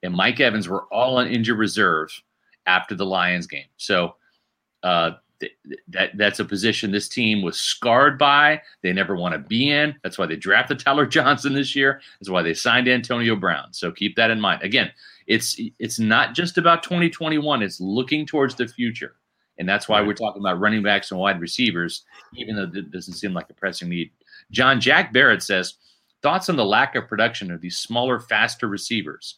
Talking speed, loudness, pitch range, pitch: 195 wpm, -20 LUFS, 95-135 Hz, 110 Hz